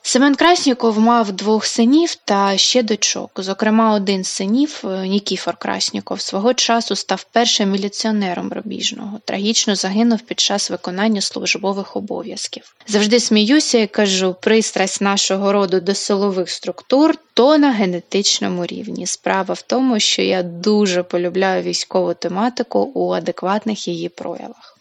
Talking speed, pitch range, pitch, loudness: 130 wpm, 190-230 Hz, 205 Hz, -17 LUFS